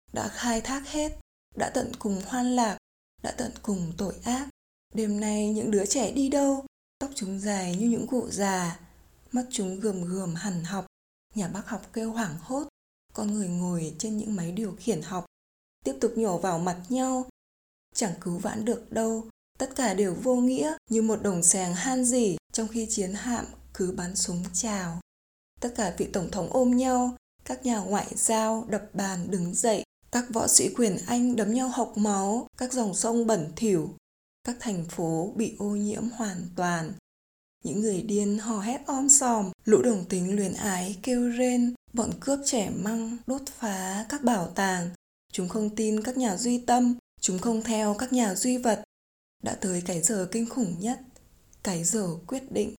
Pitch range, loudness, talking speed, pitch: 195-245 Hz, -28 LUFS, 185 wpm, 220 Hz